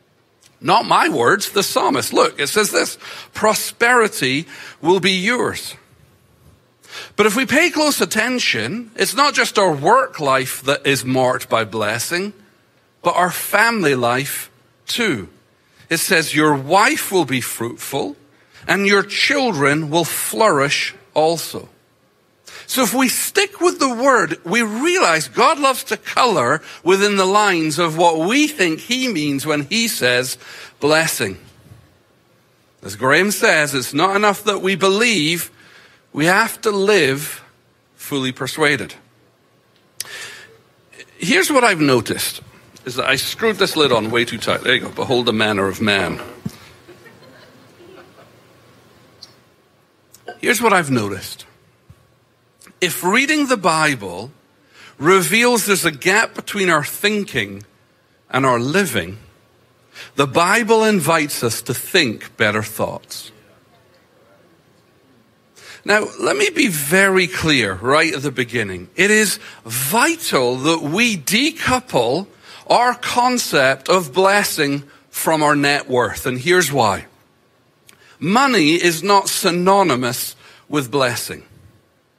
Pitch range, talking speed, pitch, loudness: 130-210 Hz, 125 wpm, 165 Hz, -16 LUFS